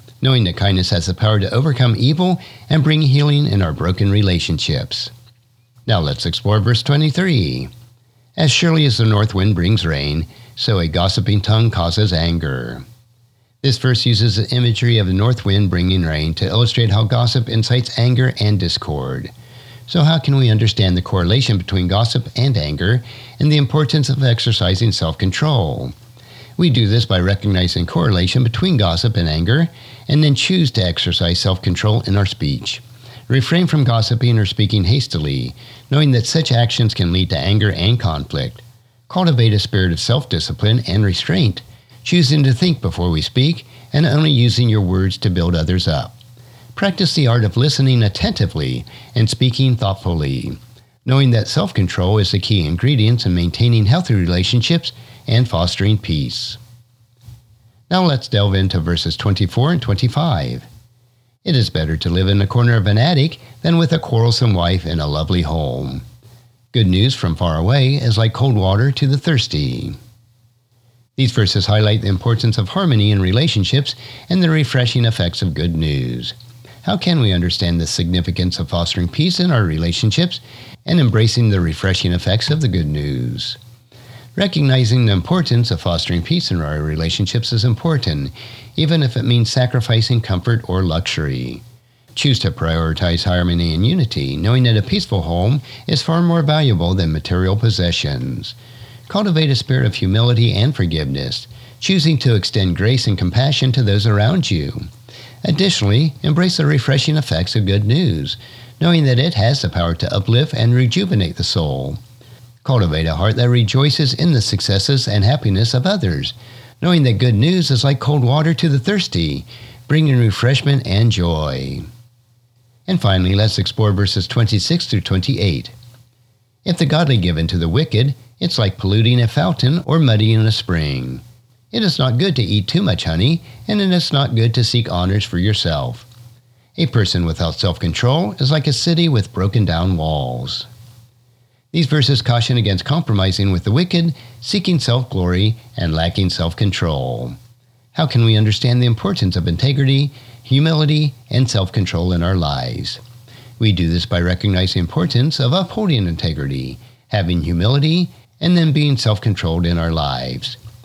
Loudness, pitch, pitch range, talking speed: -16 LUFS, 120 Hz, 95-130 Hz, 160 wpm